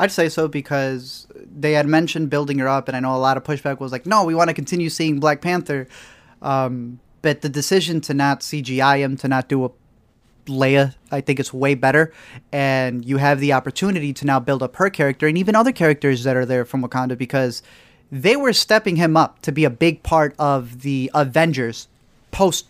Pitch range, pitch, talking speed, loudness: 130-160 Hz, 140 Hz, 210 wpm, -19 LUFS